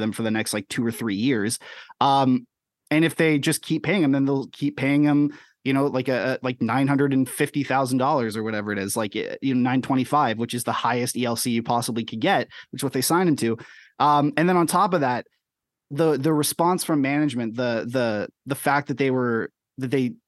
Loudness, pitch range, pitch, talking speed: -23 LUFS, 120-145 Hz, 130 Hz, 215 wpm